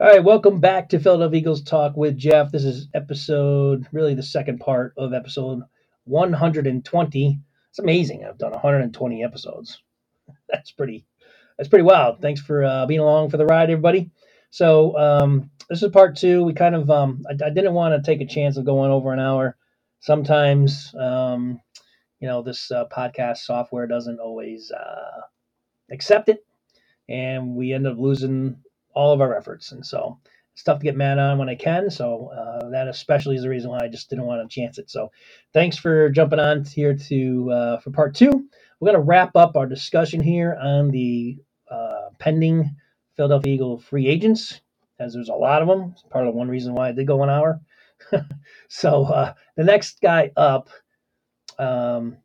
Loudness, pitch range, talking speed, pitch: -19 LUFS, 130-160 Hz, 185 wpm, 140 Hz